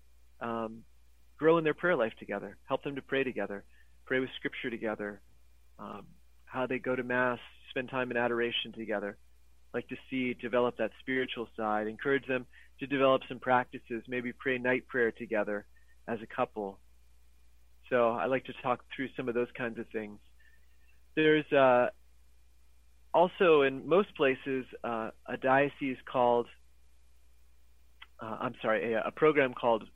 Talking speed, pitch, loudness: 155 wpm, 115 Hz, -31 LUFS